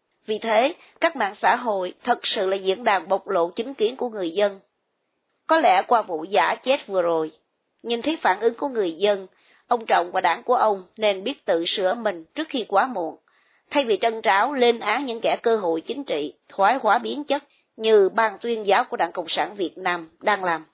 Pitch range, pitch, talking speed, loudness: 185-245 Hz, 215 Hz, 220 wpm, -22 LUFS